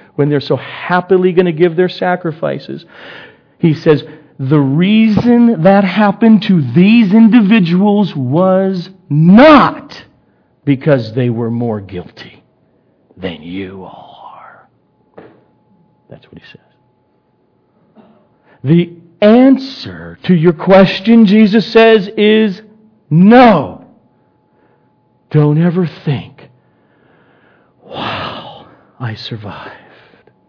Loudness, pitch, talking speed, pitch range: -10 LUFS, 180 Hz, 90 wpm, 140-210 Hz